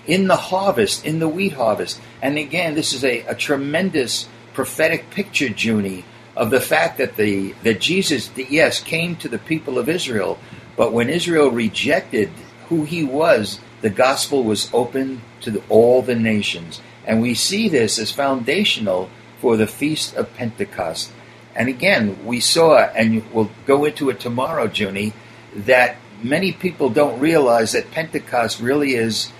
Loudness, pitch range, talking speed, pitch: -18 LUFS, 115-155 Hz, 160 wpm, 130 Hz